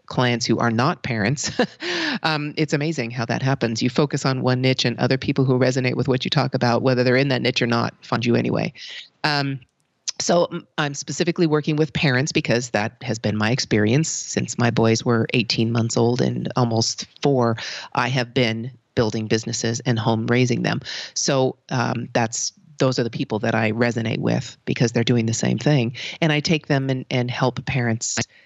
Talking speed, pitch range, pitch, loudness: 195 wpm, 115-145 Hz, 125 Hz, -21 LUFS